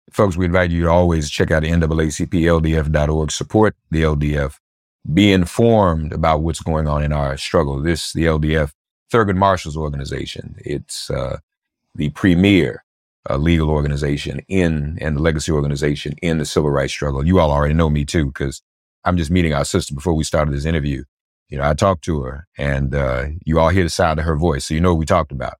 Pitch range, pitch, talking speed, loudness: 75-85 Hz, 80 Hz, 195 wpm, -18 LUFS